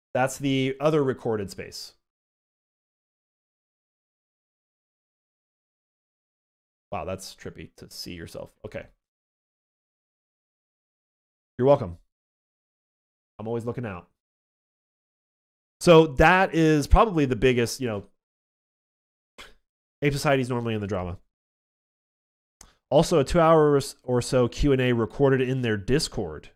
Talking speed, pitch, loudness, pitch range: 100 wpm, 125 Hz, -23 LUFS, 105-140 Hz